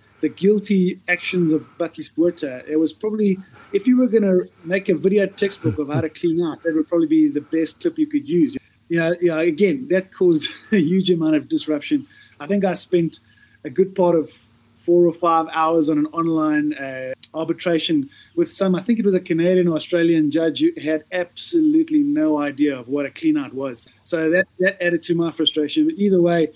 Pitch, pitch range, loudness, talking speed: 170 Hz, 155-195 Hz, -20 LUFS, 210 wpm